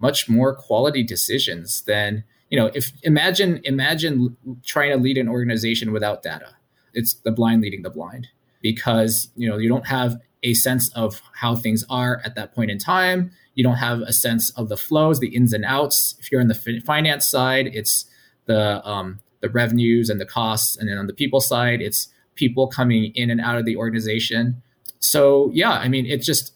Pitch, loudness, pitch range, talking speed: 120 Hz, -20 LUFS, 115-130 Hz, 195 wpm